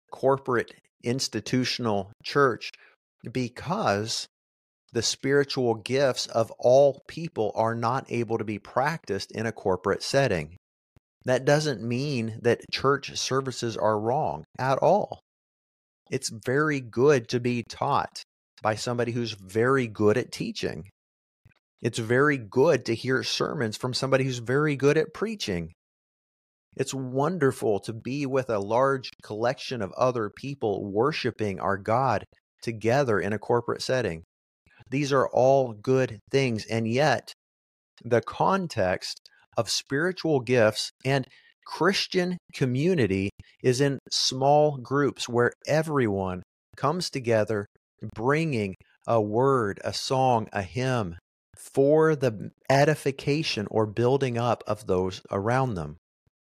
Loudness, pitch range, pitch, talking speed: -26 LUFS, 105-135 Hz, 120 Hz, 120 wpm